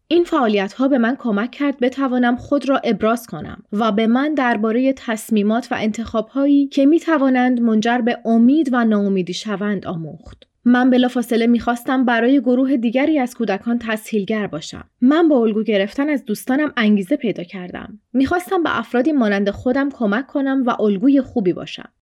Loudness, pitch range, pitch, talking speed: -18 LUFS, 215-270 Hz, 240 Hz, 160 wpm